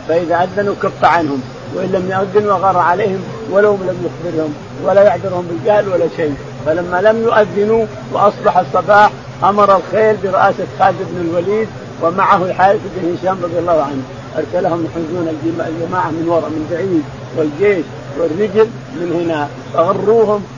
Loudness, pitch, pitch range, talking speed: -14 LUFS, 180 Hz, 160-200 Hz, 135 wpm